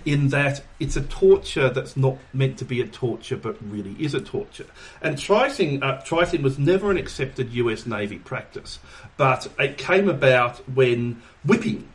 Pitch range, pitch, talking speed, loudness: 120-155 Hz, 135 Hz, 165 wpm, -23 LUFS